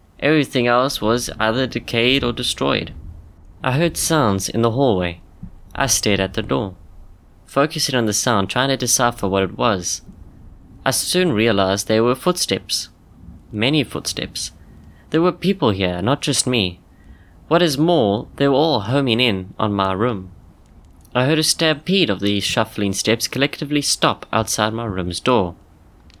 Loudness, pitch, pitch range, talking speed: -18 LUFS, 110 Hz, 95-135 Hz, 155 wpm